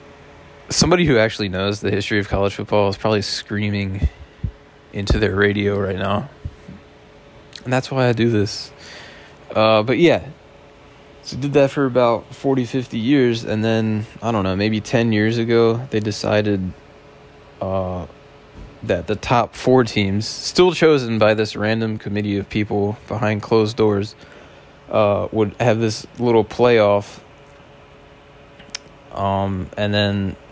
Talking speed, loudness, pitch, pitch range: 140 wpm, -19 LUFS, 110 Hz, 100-115 Hz